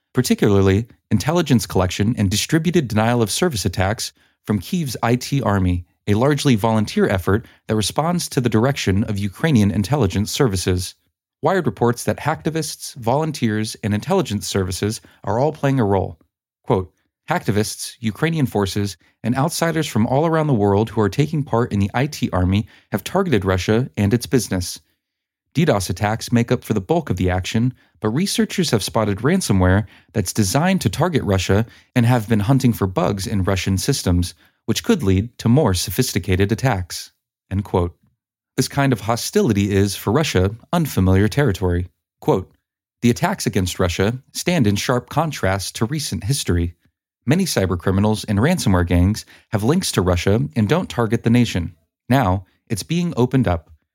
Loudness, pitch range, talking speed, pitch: -19 LUFS, 95-130 Hz, 160 wpm, 110 Hz